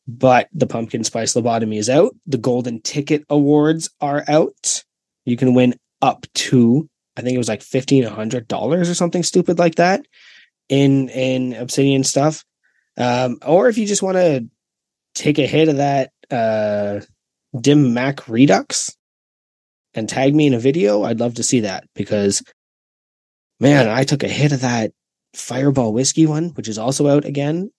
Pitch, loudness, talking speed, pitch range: 130 Hz, -17 LUFS, 170 wpm, 120-150 Hz